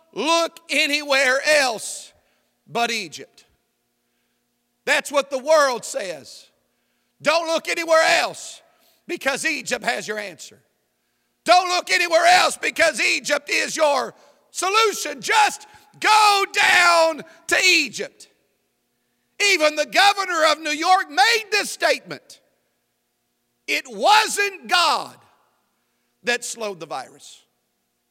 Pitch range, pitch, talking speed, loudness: 280-365 Hz, 325 Hz, 105 wpm, -19 LUFS